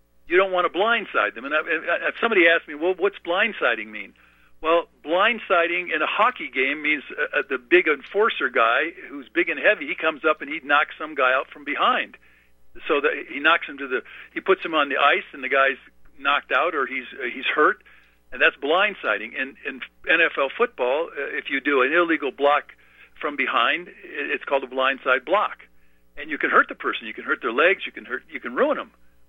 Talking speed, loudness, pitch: 205 wpm, -22 LUFS, 165 Hz